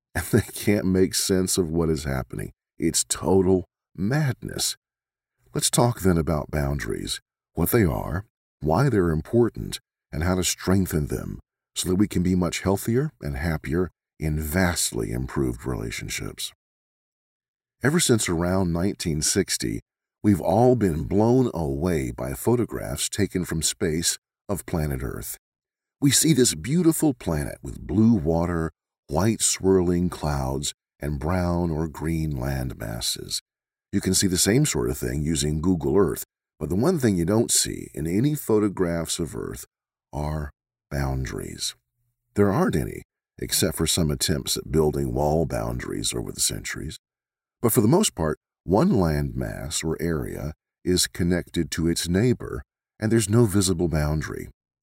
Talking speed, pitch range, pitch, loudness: 145 wpm, 75-100 Hz, 85 Hz, -24 LUFS